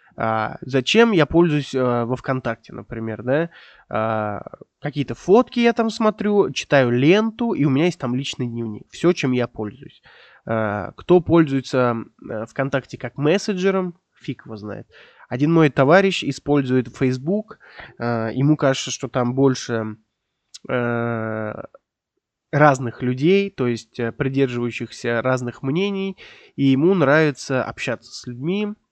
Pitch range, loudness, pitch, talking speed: 120-165 Hz, -20 LUFS, 135 Hz, 130 wpm